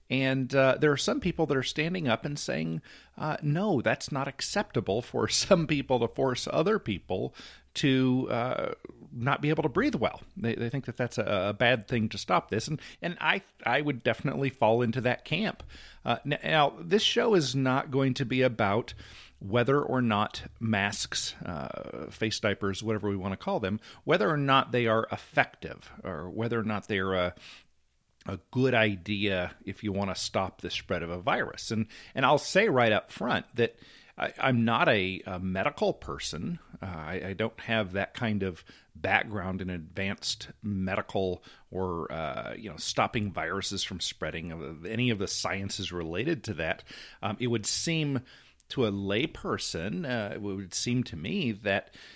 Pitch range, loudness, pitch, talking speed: 95-130 Hz, -29 LUFS, 110 Hz, 185 wpm